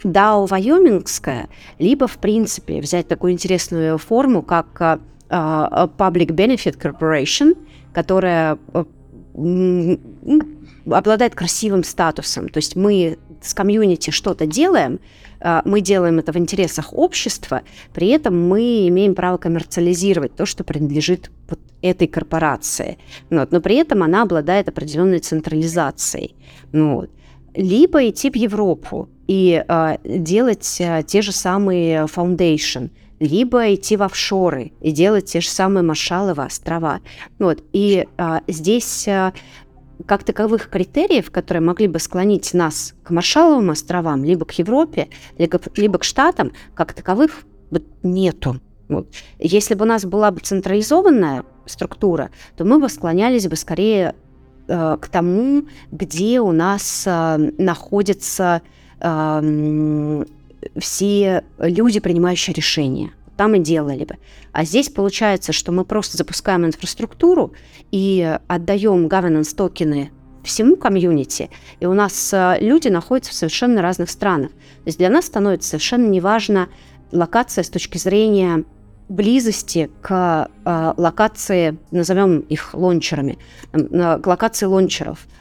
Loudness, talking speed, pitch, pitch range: -17 LUFS, 130 wpm, 180 Hz, 160-205 Hz